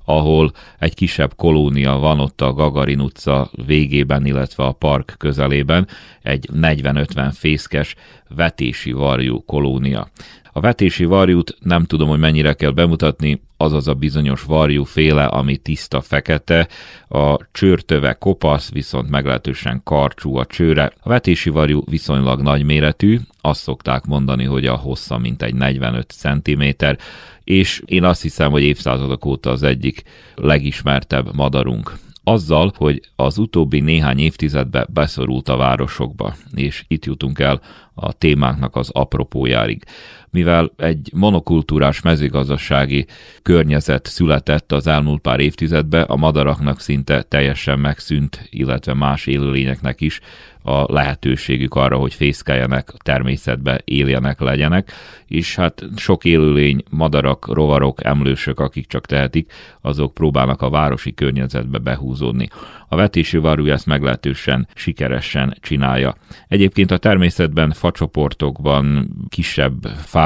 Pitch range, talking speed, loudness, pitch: 65-80 Hz, 125 wpm, -17 LUFS, 70 Hz